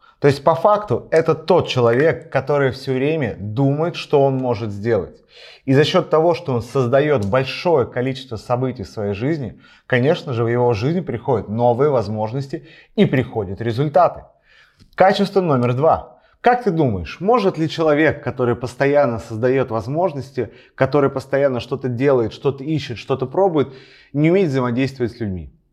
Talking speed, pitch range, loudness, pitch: 150 wpm, 120-155 Hz, -18 LUFS, 135 Hz